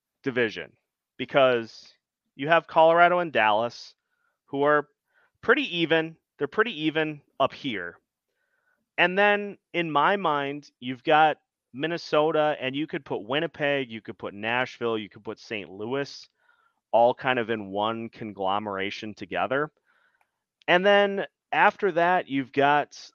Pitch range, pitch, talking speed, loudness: 125-175 Hz, 150 Hz, 130 wpm, -25 LUFS